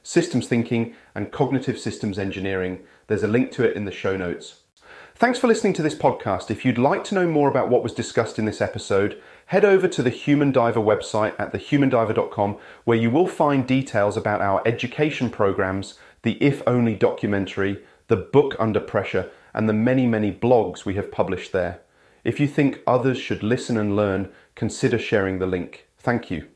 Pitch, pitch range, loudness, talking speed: 115 Hz, 105-140 Hz, -22 LUFS, 190 wpm